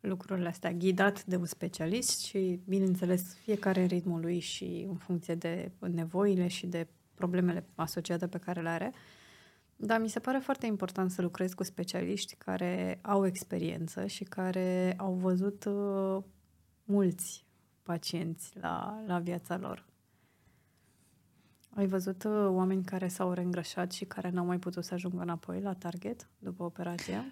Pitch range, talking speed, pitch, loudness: 175-195 Hz, 145 wpm, 185 Hz, -34 LUFS